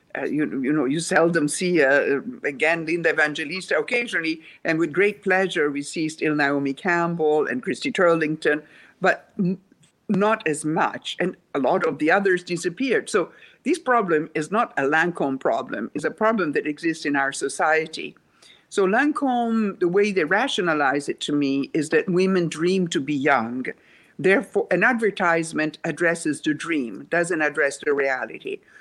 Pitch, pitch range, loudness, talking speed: 170 Hz, 155-200 Hz, -22 LUFS, 160 wpm